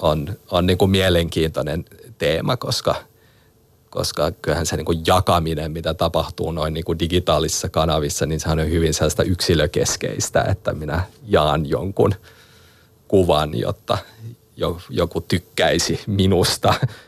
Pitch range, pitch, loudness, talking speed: 80-95 Hz, 85 Hz, -20 LUFS, 125 wpm